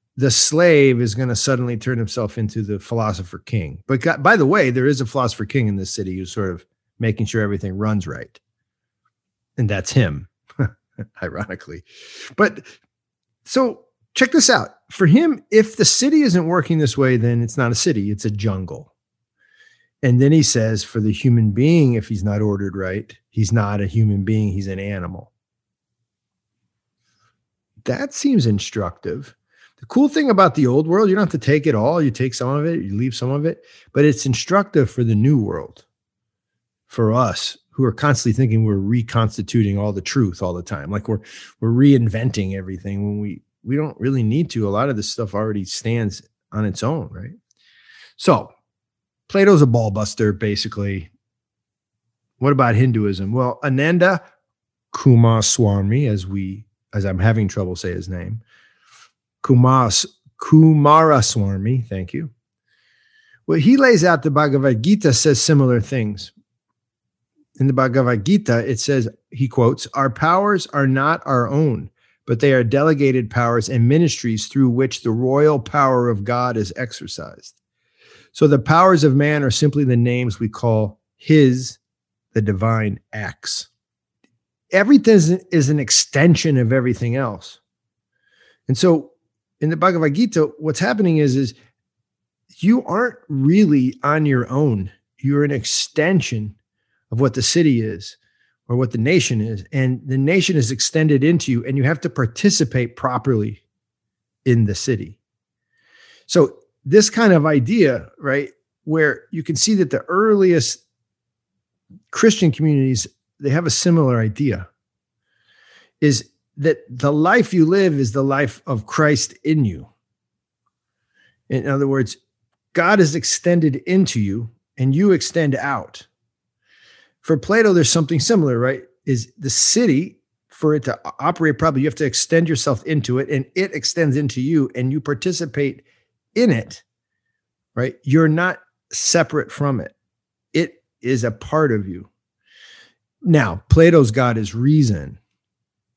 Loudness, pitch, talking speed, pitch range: -17 LUFS, 130 Hz, 155 wpm, 110-155 Hz